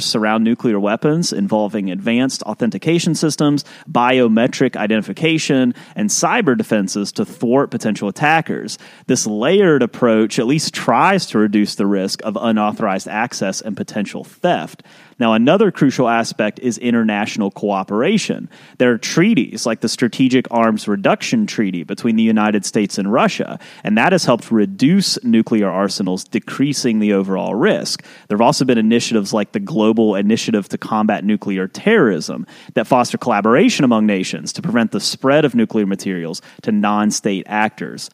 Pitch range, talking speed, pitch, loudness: 105-130 Hz, 150 wpm, 110 Hz, -16 LUFS